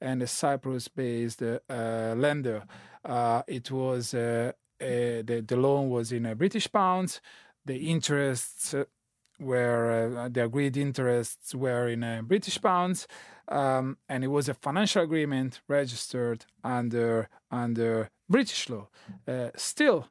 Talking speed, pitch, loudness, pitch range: 135 wpm, 125 Hz, -29 LUFS, 120-140 Hz